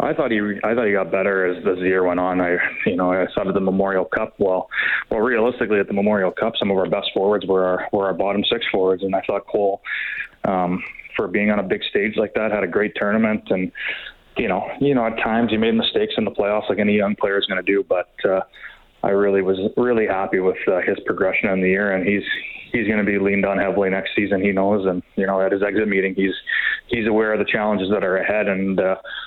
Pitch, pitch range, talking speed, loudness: 100 Hz, 95-105 Hz, 250 wpm, -20 LUFS